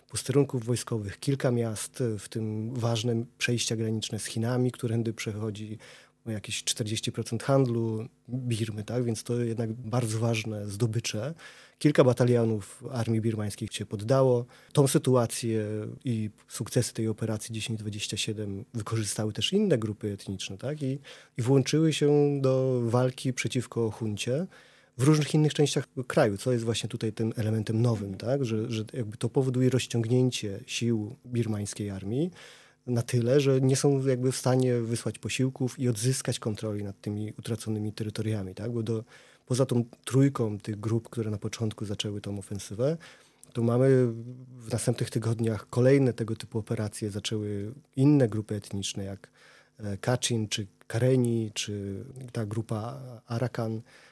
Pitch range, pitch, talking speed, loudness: 110-125 Hz, 115 Hz, 140 wpm, -29 LUFS